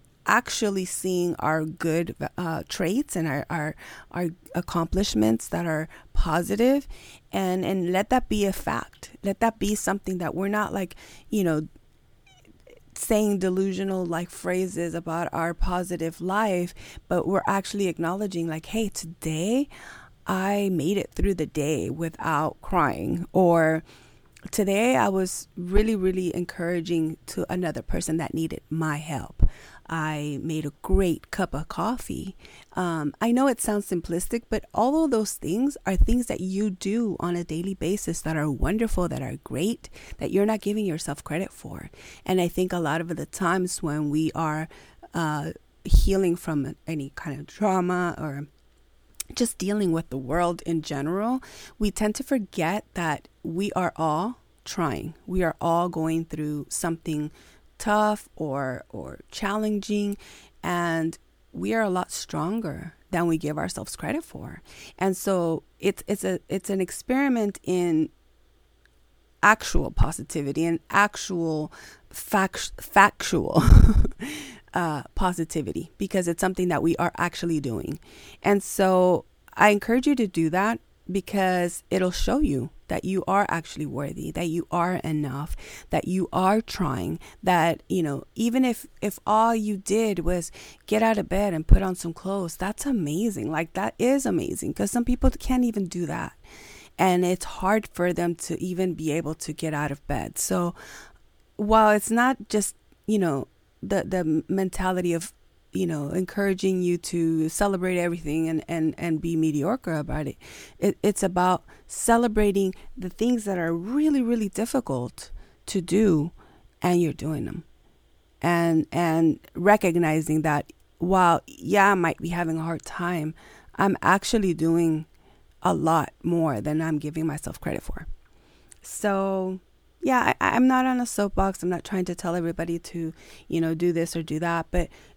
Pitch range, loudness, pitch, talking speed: 165-200 Hz, -25 LUFS, 180 Hz, 155 wpm